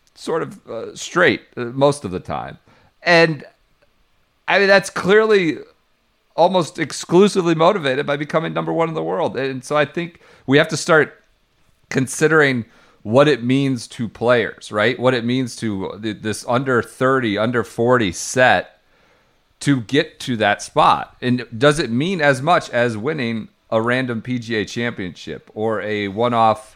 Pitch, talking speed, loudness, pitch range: 130 Hz, 155 wpm, -18 LUFS, 115-155 Hz